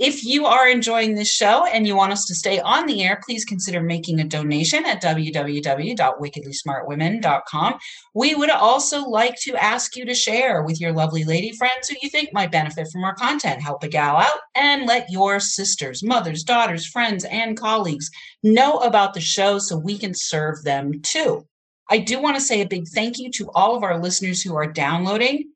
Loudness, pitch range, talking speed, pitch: -19 LUFS, 160-240 Hz, 195 wpm, 200 Hz